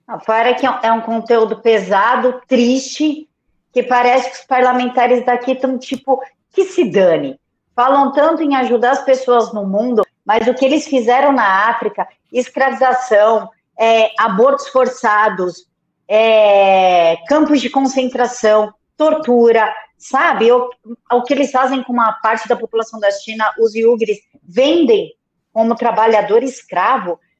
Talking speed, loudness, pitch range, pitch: 135 wpm, -14 LUFS, 220-260 Hz, 245 Hz